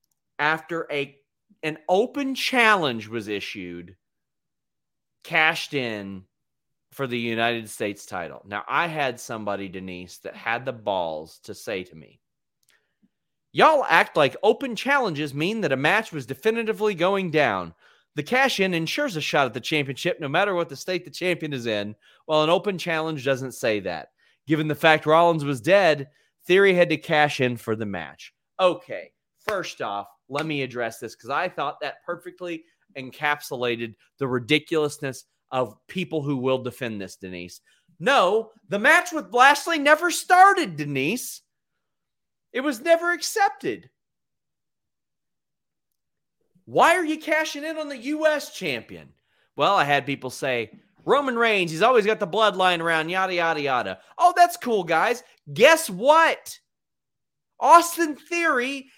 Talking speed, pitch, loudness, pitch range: 150 wpm, 160 Hz, -22 LUFS, 130-220 Hz